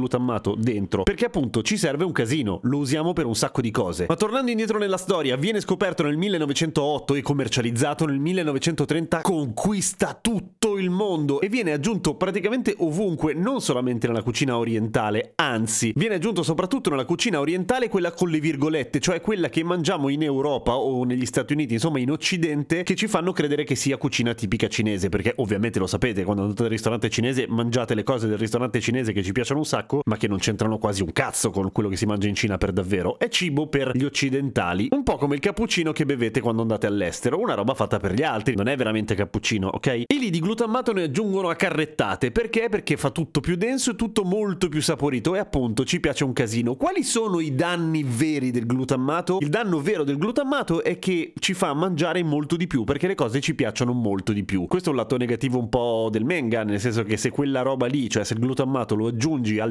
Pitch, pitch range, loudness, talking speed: 145 Hz, 120-175 Hz, -23 LUFS, 215 wpm